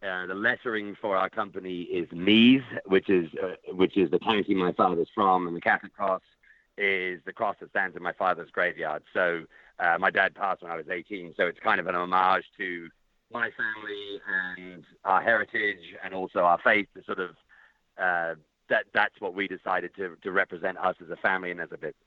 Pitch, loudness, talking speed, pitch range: 95 Hz, -27 LUFS, 205 wpm, 90-100 Hz